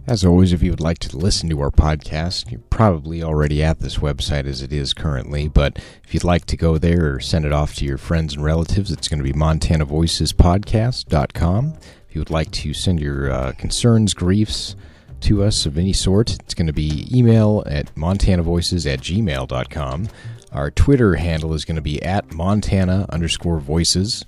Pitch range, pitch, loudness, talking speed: 75-95 Hz, 80 Hz, -19 LUFS, 190 wpm